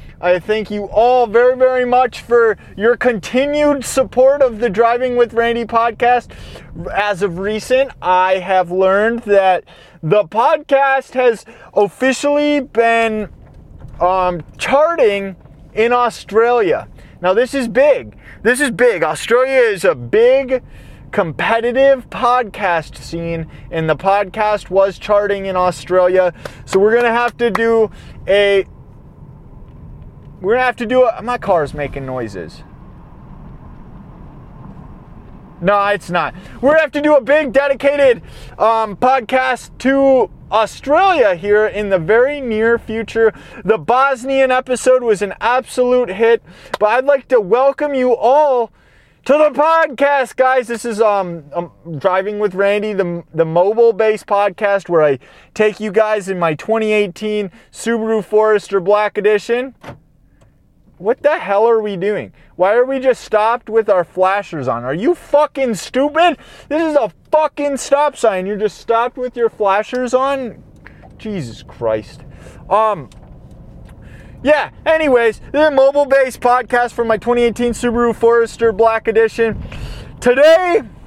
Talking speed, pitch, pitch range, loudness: 140 wpm, 225 Hz, 200-255 Hz, -15 LUFS